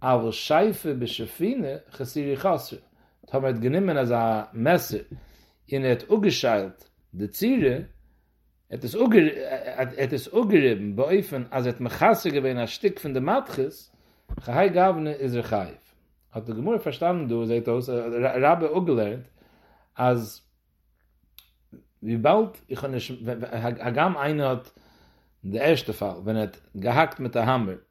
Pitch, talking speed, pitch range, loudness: 125 Hz, 130 wpm, 110-140 Hz, -25 LUFS